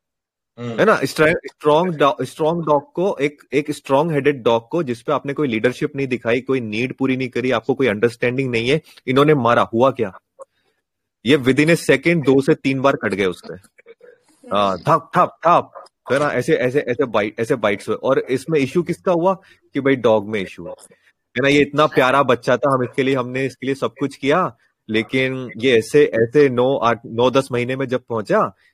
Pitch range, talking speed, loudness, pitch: 125-150 Hz, 160 wpm, -18 LUFS, 135 Hz